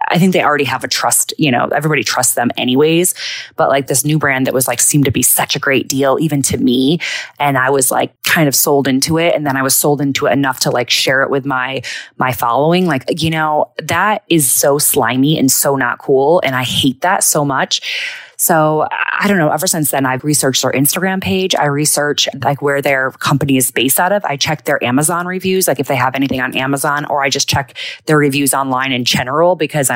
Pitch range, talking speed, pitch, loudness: 135-155 Hz, 235 wpm, 145 Hz, -13 LUFS